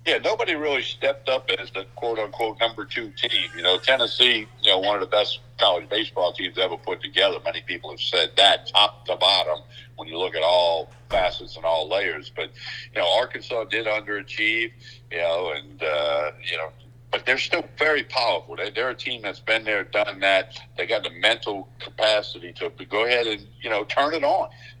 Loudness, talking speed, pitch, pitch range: -23 LUFS, 200 wpm, 115 Hz, 105-125 Hz